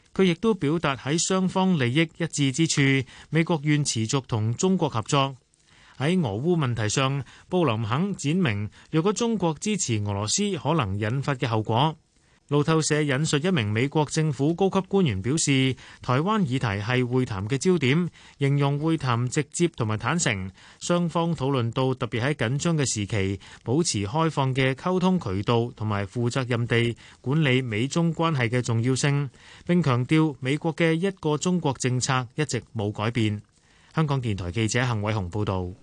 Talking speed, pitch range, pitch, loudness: 260 characters per minute, 115-165 Hz, 140 Hz, -25 LUFS